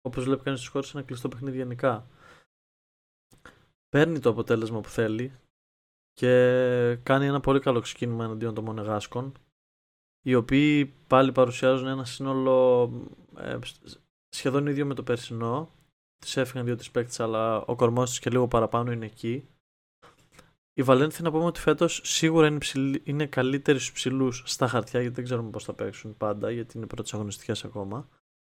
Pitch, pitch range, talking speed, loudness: 125 Hz, 115-135 Hz, 150 wpm, -26 LUFS